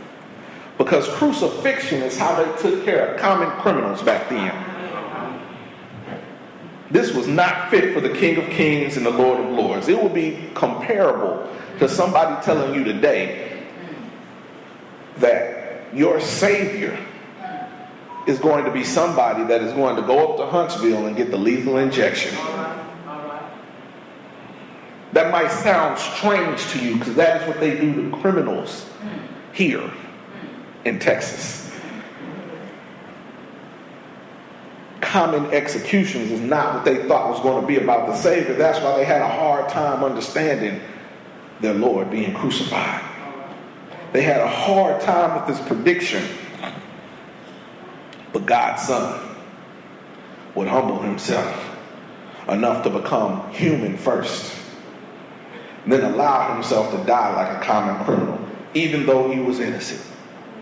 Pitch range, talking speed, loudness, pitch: 145-205 Hz, 135 wpm, -20 LUFS, 165 Hz